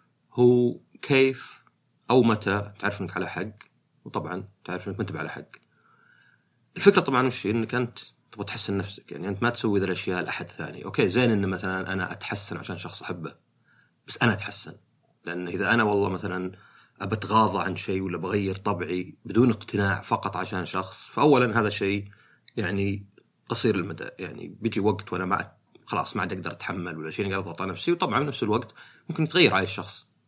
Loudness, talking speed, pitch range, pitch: -26 LUFS, 170 wpm, 95-115 Hz, 100 Hz